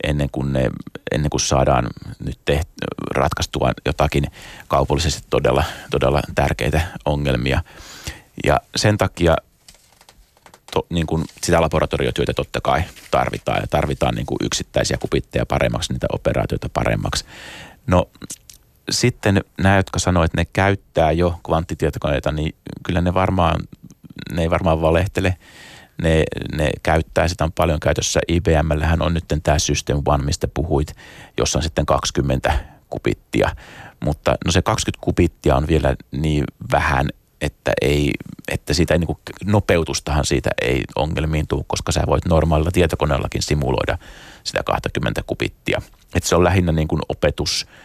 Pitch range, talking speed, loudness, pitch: 70-85 Hz, 140 wpm, -20 LUFS, 80 Hz